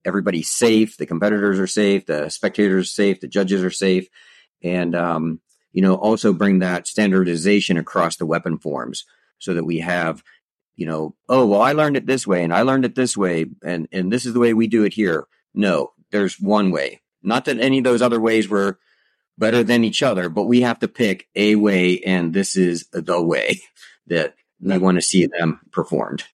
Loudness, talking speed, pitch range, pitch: -19 LUFS, 205 wpm, 90-110 Hz, 100 Hz